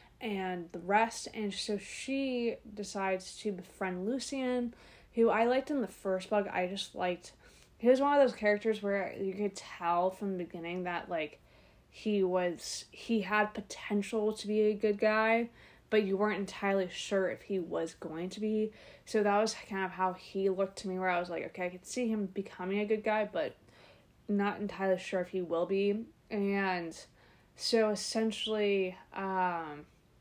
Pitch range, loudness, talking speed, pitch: 185-215 Hz, -33 LUFS, 180 wpm, 200 Hz